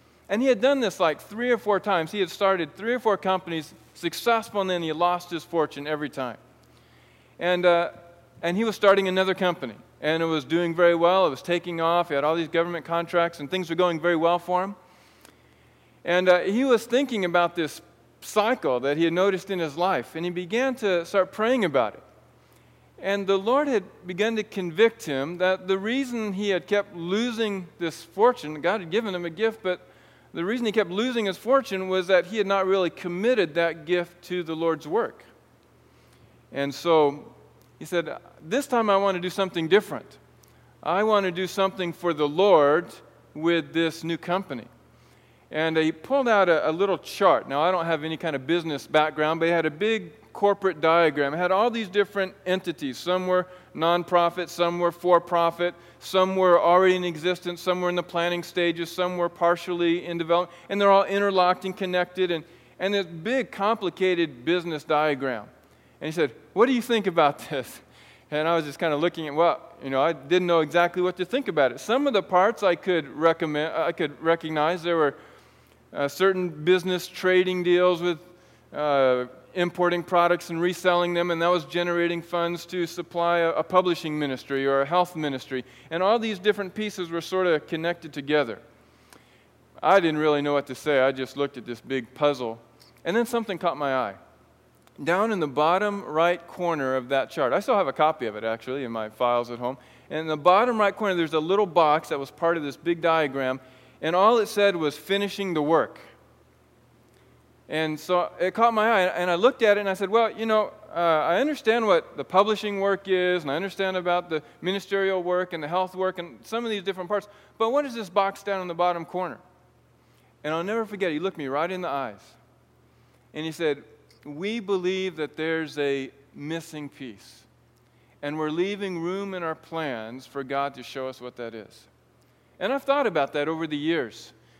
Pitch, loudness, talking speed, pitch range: 175 Hz, -25 LUFS, 205 wpm, 160-190 Hz